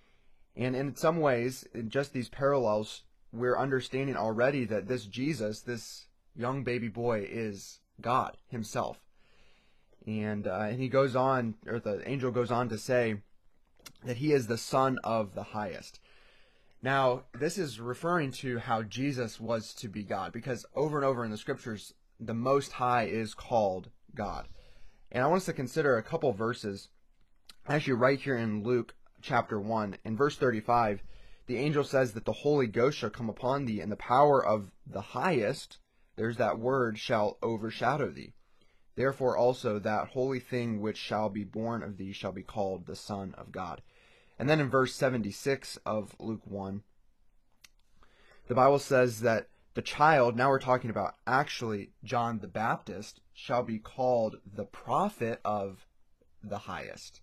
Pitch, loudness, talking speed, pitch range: 120 Hz, -31 LUFS, 165 wpm, 105-130 Hz